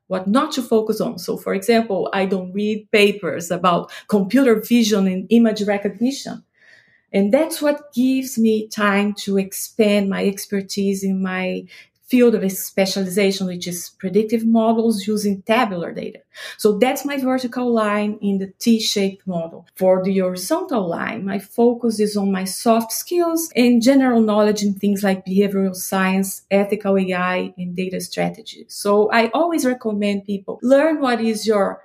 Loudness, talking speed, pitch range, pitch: -19 LUFS, 155 wpm, 195-230 Hz, 210 Hz